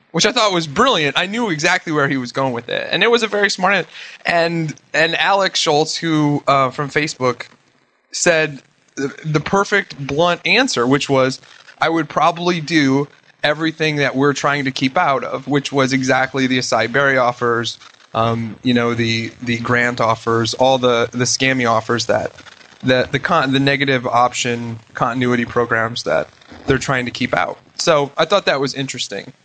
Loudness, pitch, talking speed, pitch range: -17 LUFS, 135 Hz, 180 wpm, 125-160 Hz